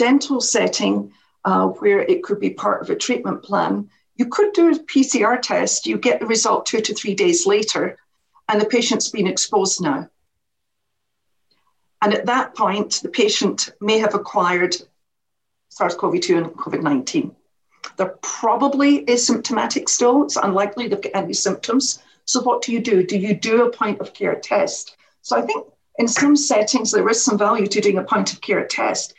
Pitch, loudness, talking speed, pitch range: 240 Hz, -19 LUFS, 180 wpm, 210-285 Hz